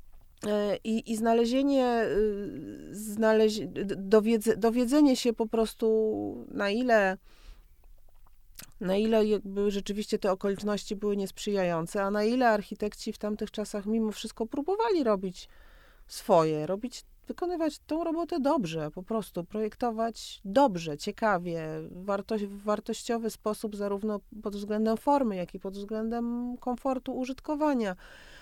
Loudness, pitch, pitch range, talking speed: -29 LUFS, 215 Hz, 200-235 Hz, 115 wpm